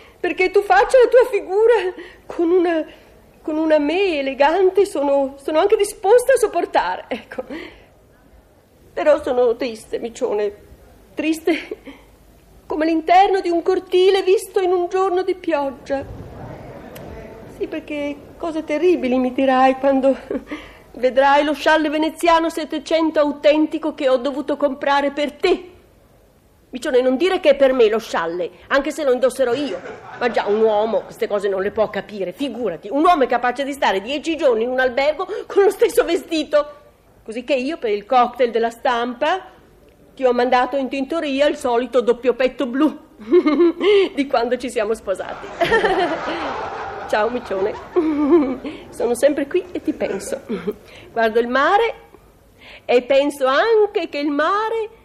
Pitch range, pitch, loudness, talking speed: 260-360 Hz, 295 Hz, -18 LUFS, 145 wpm